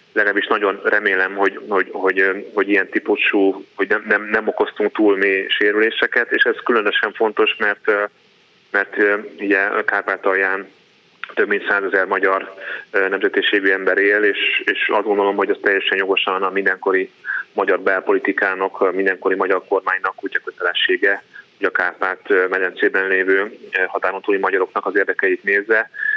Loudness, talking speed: -18 LUFS, 145 wpm